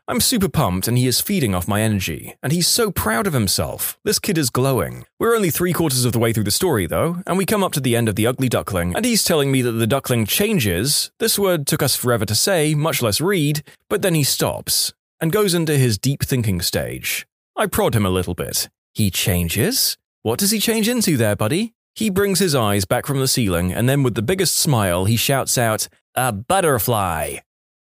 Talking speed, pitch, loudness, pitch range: 225 wpm, 135 Hz, -19 LUFS, 110-175 Hz